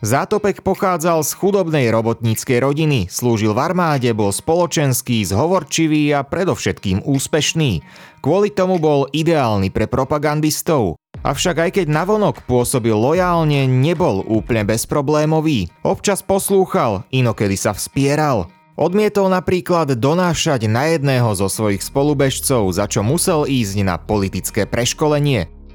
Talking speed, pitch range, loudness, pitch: 120 wpm, 115-165 Hz, -17 LUFS, 140 Hz